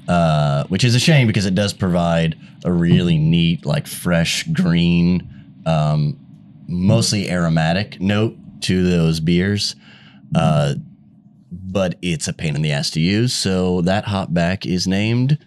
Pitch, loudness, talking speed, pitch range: 95 Hz, -18 LUFS, 145 wpm, 85-125 Hz